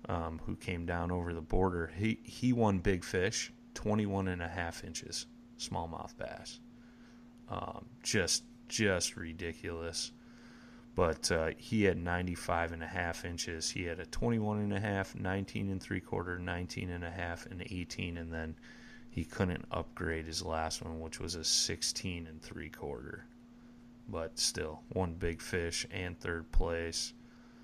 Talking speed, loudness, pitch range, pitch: 150 wpm, -36 LUFS, 85-115 Hz, 90 Hz